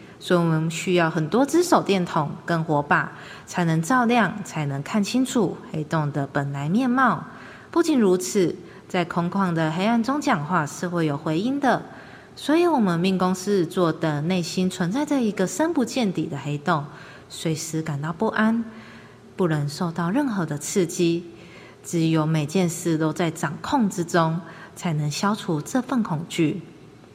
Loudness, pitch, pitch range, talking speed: -23 LUFS, 180 Hz, 160-210 Hz, 235 characters per minute